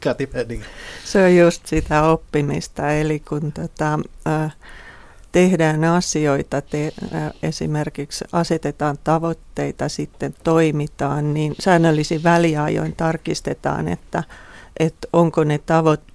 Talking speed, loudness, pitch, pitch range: 100 wpm, -20 LUFS, 155 Hz, 150-165 Hz